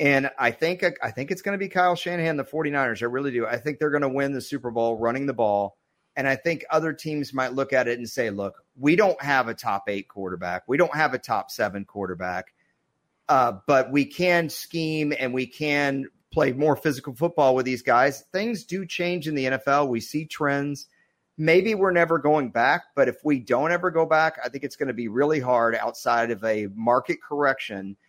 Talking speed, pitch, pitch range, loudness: 220 wpm, 140 Hz, 120-160 Hz, -24 LUFS